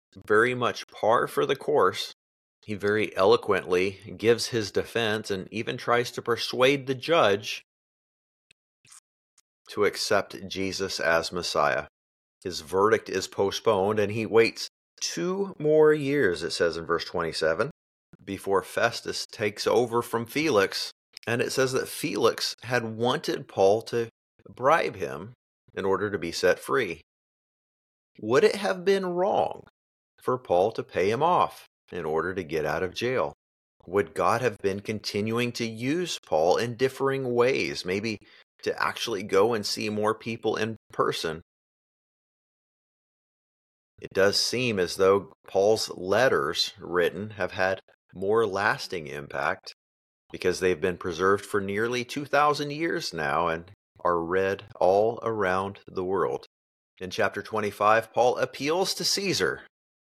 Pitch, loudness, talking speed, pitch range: 105 Hz, -26 LUFS, 135 wpm, 95-125 Hz